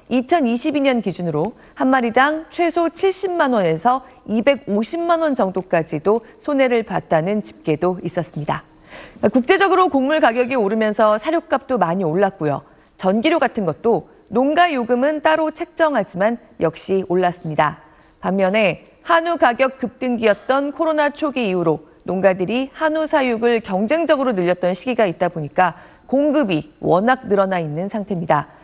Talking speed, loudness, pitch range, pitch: 305 characters per minute, -19 LUFS, 180-285 Hz, 230 Hz